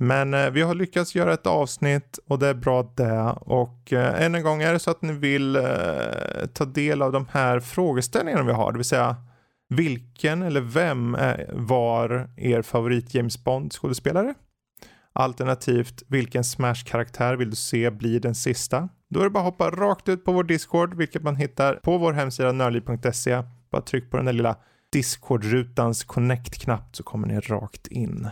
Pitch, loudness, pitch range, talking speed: 130 Hz, -24 LUFS, 120-155 Hz, 175 wpm